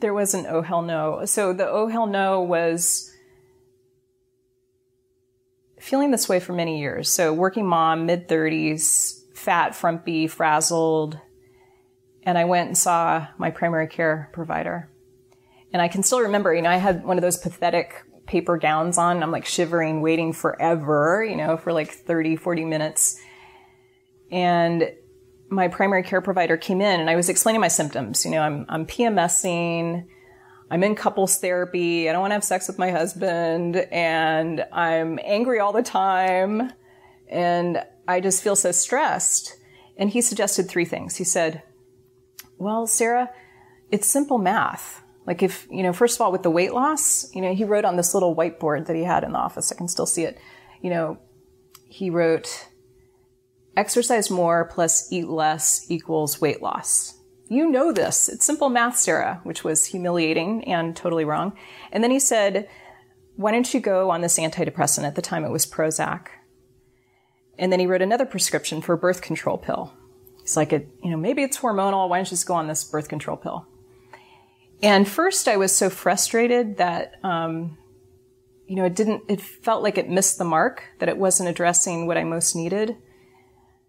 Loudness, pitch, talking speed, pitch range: -22 LUFS, 170 Hz, 175 wpm, 155-190 Hz